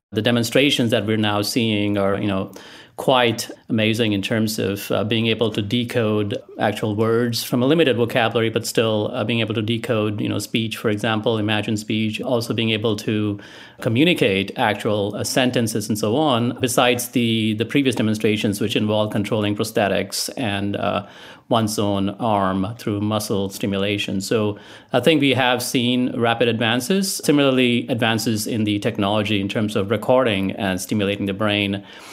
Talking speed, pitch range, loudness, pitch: 165 wpm, 105-120 Hz, -20 LUFS, 110 Hz